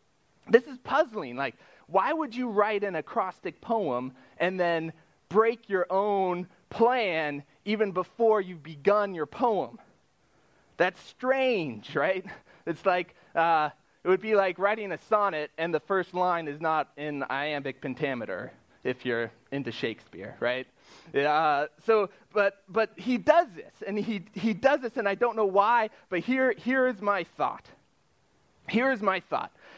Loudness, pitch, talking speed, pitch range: -28 LUFS, 195 Hz, 155 wpm, 155-225 Hz